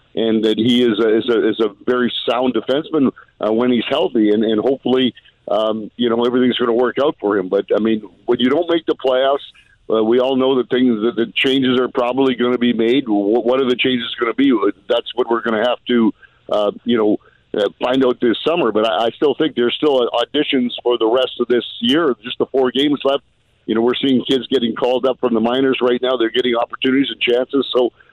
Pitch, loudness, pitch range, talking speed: 125 Hz, -17 LUFS, 115-130 Hz, 240 wpm